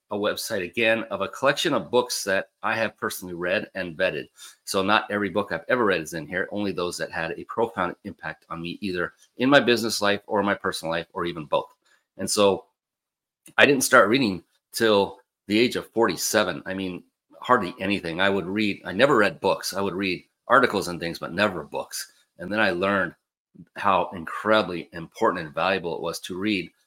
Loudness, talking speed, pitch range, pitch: -24 LUFS, 200 wpm, 90-105 Hz, 100 Hz